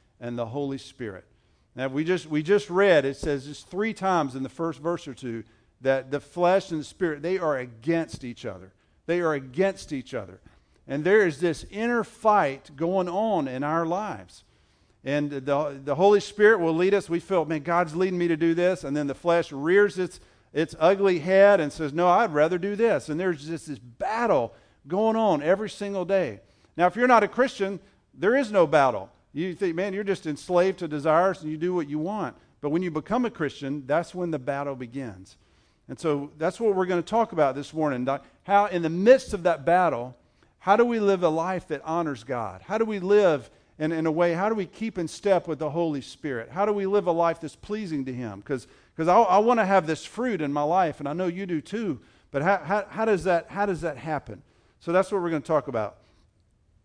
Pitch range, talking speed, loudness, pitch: 140-195 Hz, 230 wpm, -25 LUFS, 165 Hz